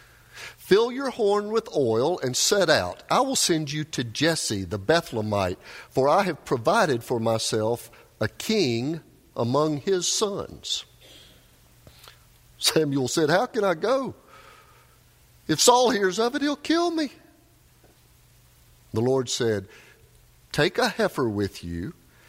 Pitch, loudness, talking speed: 155 Hz, -24 LUFS, 130 wpm